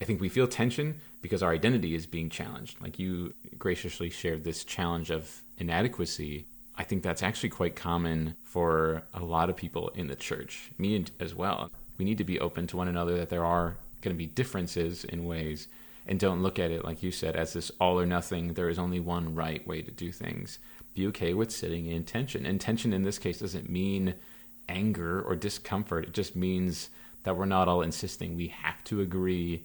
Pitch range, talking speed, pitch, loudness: 85-95 Hz, 210 wpm, 90 Hz, -32 LUFS